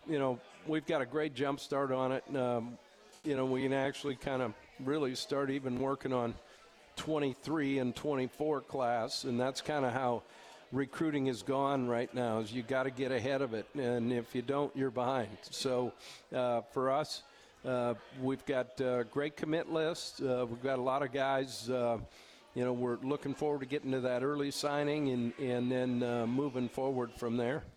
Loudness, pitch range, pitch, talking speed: -35 LUFS, 125-140 Hz, 130 Hz, 190 wpm